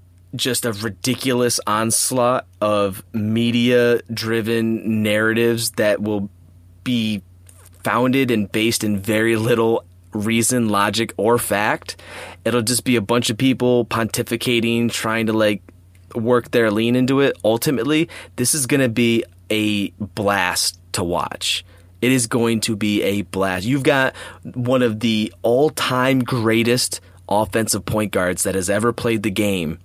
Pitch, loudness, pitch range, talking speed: 115 Hz, -19 LUFS, 100-120 Hz, 140 wpm